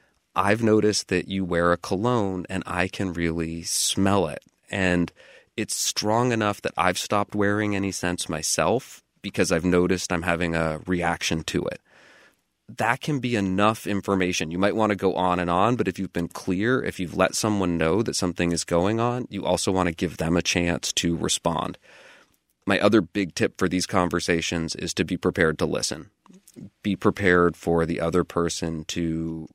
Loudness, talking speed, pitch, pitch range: -24 LUFS, 185 wpm, 90 Hz, 85-100 Hz